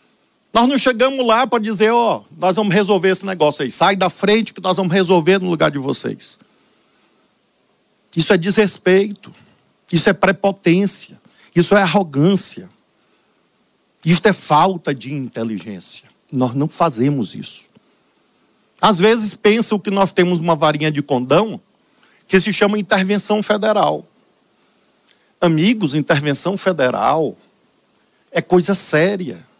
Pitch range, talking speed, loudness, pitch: 170-210 Hz, 130 wpm, -16 LUFS, 190 Hz